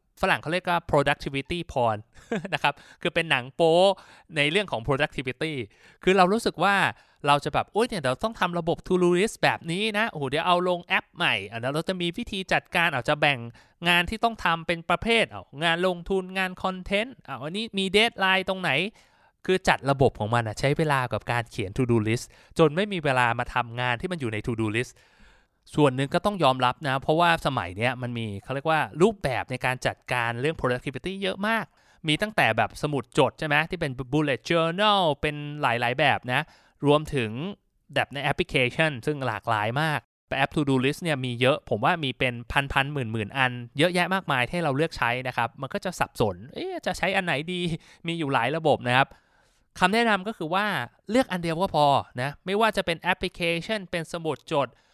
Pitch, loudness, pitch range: 155 Hz, -25 LUFS, 130-185 Hz